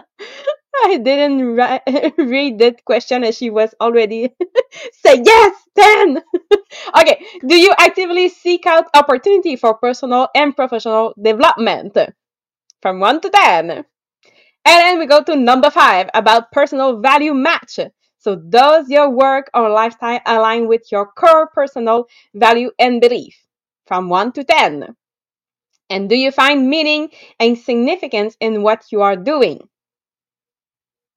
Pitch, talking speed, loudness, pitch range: 270 Hz, 135 wpm, -13 LUFS, 230-325 Hz